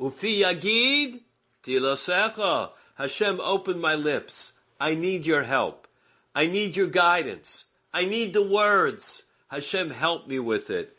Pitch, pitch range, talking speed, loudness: 185 Hz, 155-210 Hz, 120 wpm, -25 LUFS